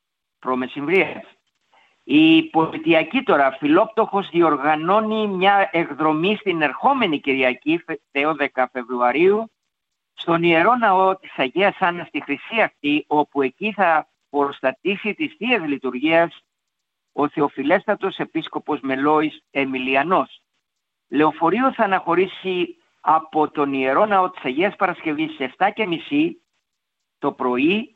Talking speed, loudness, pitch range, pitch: 100 wpm, -20 LUFS, 145-200 Hz, 160 Hz